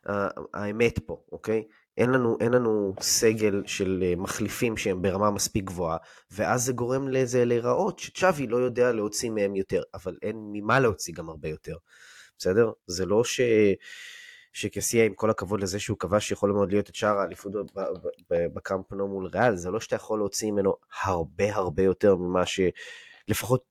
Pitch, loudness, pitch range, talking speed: 105 Hz, -26 LUFS, 100-120 Hz, 160 wpm